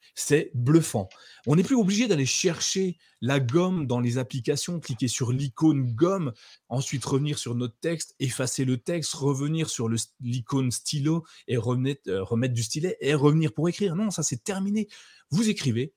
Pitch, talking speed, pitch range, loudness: 140 Hz, 175 wpm, 125-165 Hz, -26 LUFS